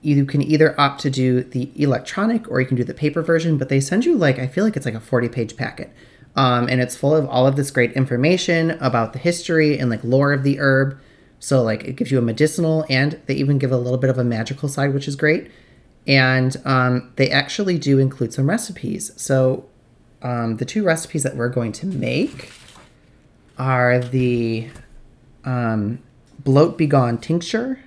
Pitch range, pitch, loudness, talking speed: 125-150 Hz, 135 Hz, -19 LUFS, 200 wpm